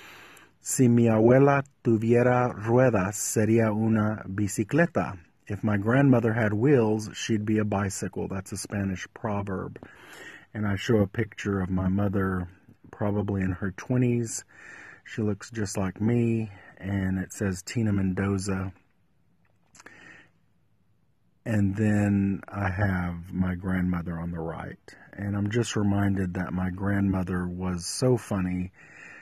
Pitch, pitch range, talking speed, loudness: 100 Hz, 95-115 Hz, 125 wpm, -26 LUFS